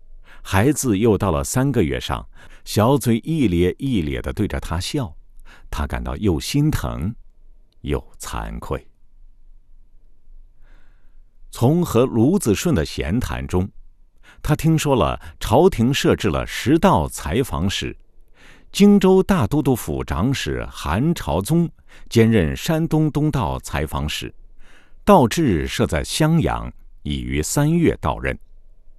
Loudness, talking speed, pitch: -20 LUFS, 175 characters per minute, 95 Hz